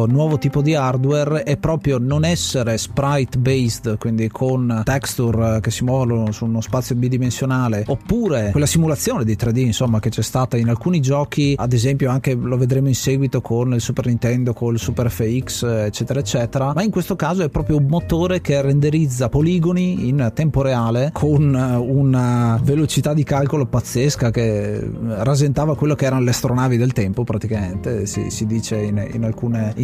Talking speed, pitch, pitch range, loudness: 170 wpm, 130 Hz, 115-145 Hz, -18 LUFS